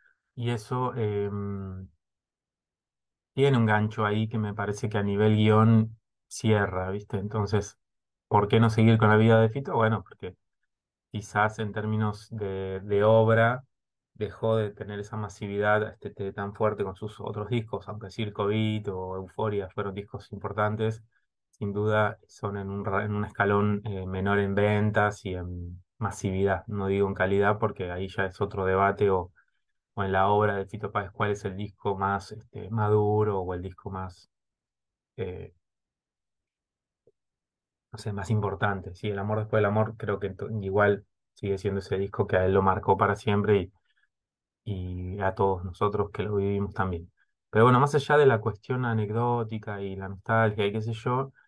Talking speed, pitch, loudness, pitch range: 170 wpm, 105 Hz, -27 LUFS, 100-110 Hz